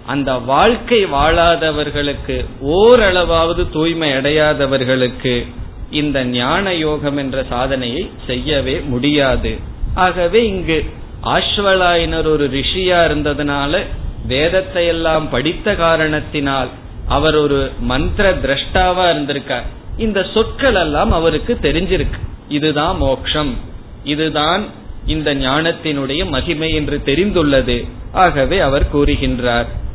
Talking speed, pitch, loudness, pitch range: 90 wpm, 150 Hz, -15 LUFS, 135-165 Hz